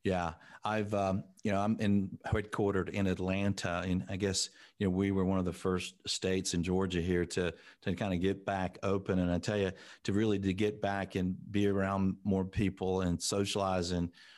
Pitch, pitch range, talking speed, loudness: 95 Hz, 90-100 Hz, 205 wpm, -33 LUFS